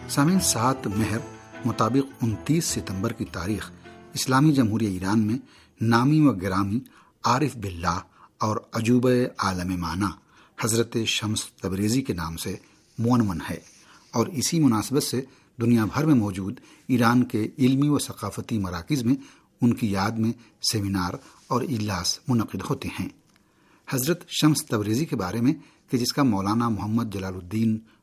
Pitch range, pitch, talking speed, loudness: 100-130 Hz, 115 Hz, 140 wpm, -25 LUFS